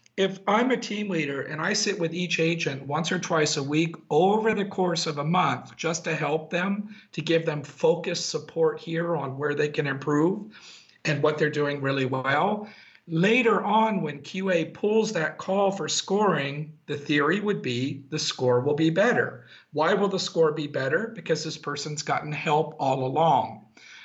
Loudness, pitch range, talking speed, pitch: -25 LUFS, 150-190 Hz, 185 wpm, 160 Hz